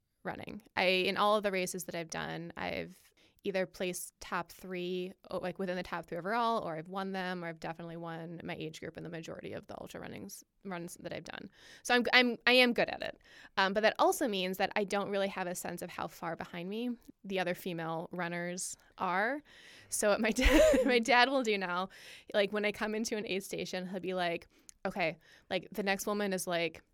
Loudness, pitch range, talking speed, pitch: -33 LUFS, 175-215 Hz, 225 wpm, 190 Hz